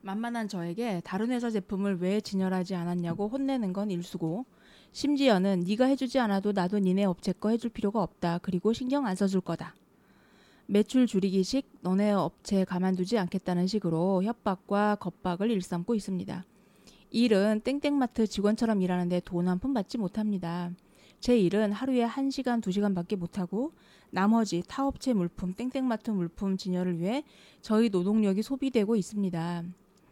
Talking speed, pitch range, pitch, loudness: 340 characters per minute, 185-230 Hz, 200 Hz, -29 LUFS